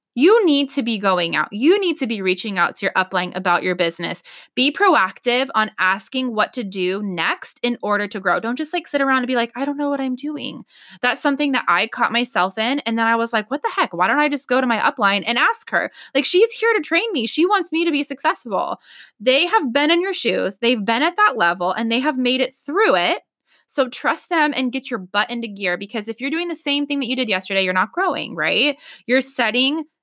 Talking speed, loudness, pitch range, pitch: 250 wpm, -19 LUFS, 215-295 Hz, 255 Hz